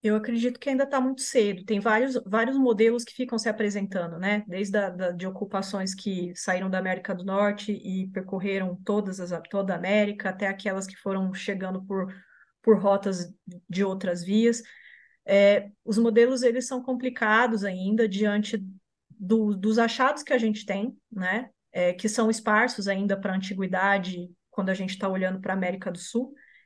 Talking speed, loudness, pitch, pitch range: 180 wpm, -26 LUFS, 200 Hz, 190-225 Hz